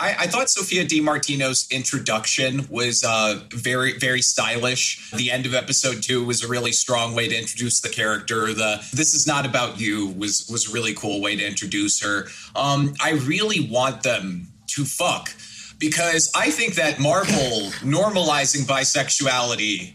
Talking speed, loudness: 160 wpm, -20 LUFS